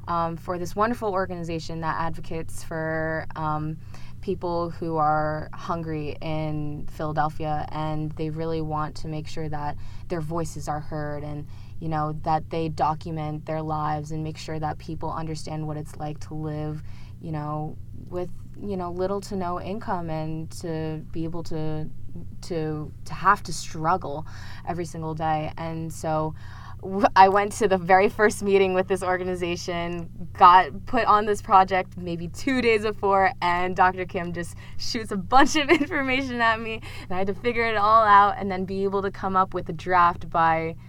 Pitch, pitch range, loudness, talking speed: 165 Hz, 155-190 Hz, -25 LUFS, 175 wpm